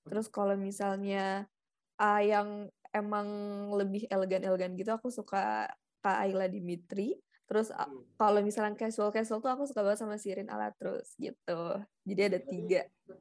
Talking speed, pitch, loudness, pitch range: 125 wpm, 200 Hz, -34 LUFS, 190-210 Hz